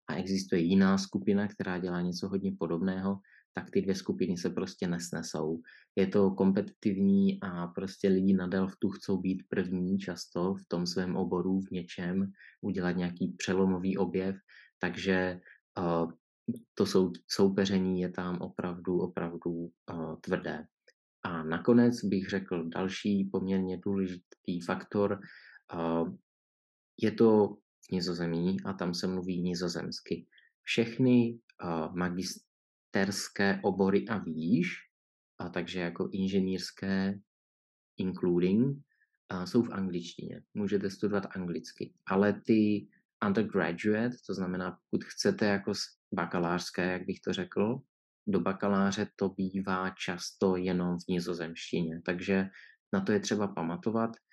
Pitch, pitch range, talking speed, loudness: 95 Hz, 90-100 Hz, 125 wpm, -32 LUFS